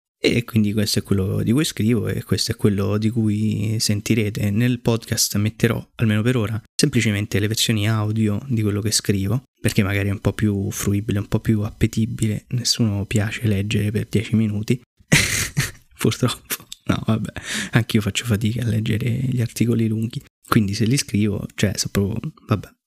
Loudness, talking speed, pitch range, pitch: -21 LUFS, 175 wpm, 105-115 Hz, 110 Hz